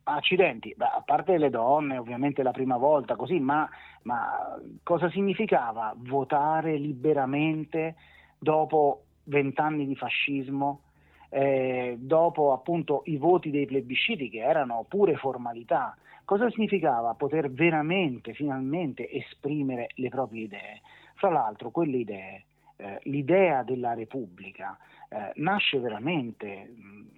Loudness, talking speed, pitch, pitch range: -27 LUFS, 115 wpm, 140 Hz, 130-160 Hz